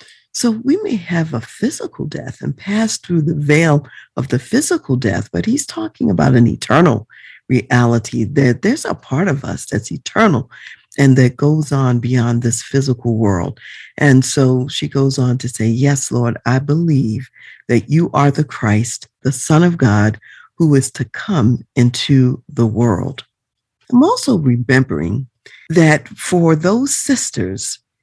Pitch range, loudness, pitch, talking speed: 120-160 Hz, -15 LUFS, 135 Hz, 155 wpm